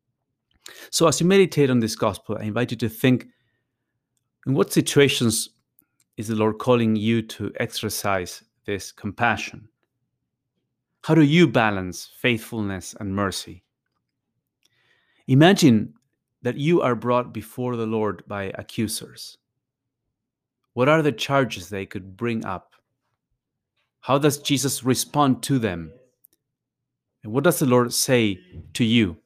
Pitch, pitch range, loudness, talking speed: 120 Hz, 110-130 Hz, -22 LUFS, 130 wpm